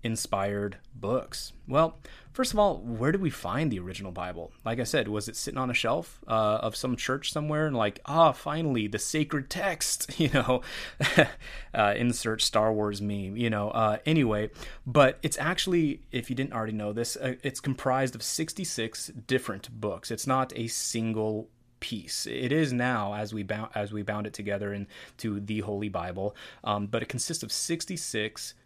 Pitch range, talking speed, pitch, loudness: 105-140 Hz, 185 wpm, 115 Hz, -29 LUFS